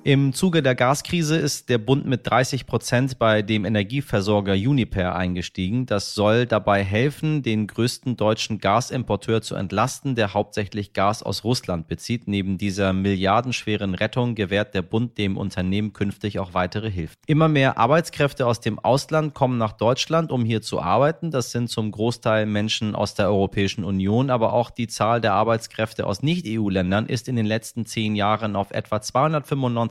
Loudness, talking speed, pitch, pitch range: -22 LUFS, 165 wpm, 110 Hz, 100-125 Hz